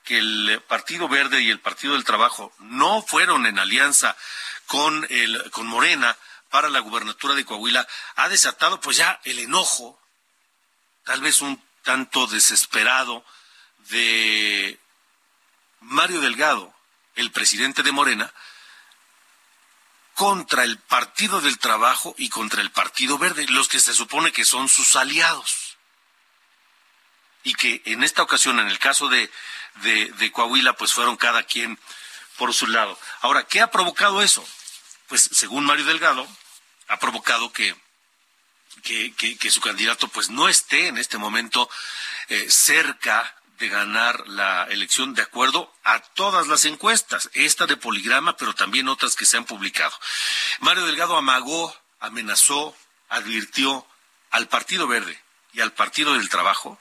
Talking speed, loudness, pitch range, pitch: 145 wpm, -19 LUFS, 110-140 Hz, 120 Hz